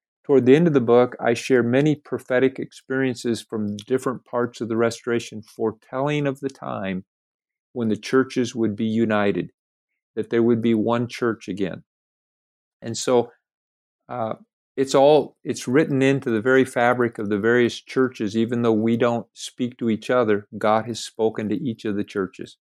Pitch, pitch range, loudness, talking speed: 120 Hz, 110-130 Hz, -22 LUFS, 170 wpm